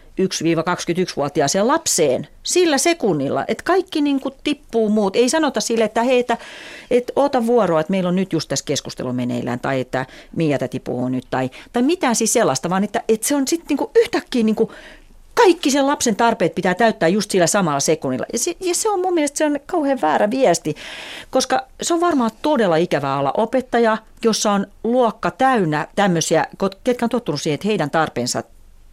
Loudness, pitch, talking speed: -19 LUFS, 220 Hz, 185 wpm